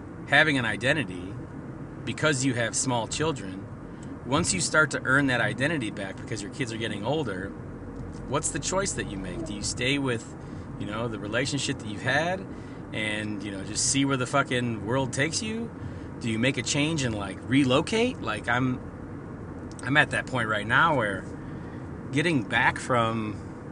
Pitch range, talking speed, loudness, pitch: 110-140 Hz, 175 wpm, -26 LUFS, 125 Hz